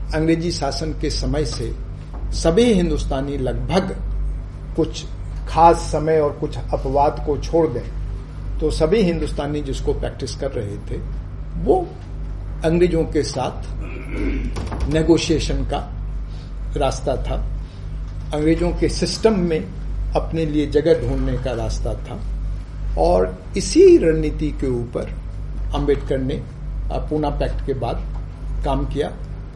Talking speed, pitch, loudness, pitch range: 115 wpm, 145 Hz, -21 LUFS, 110-160 Hz